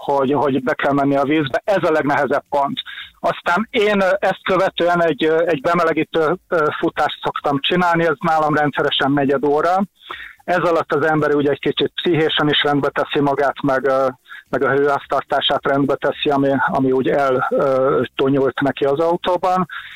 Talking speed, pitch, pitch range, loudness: 155 wpm, 150 Hz, 140-170 Hz, -17 LUFS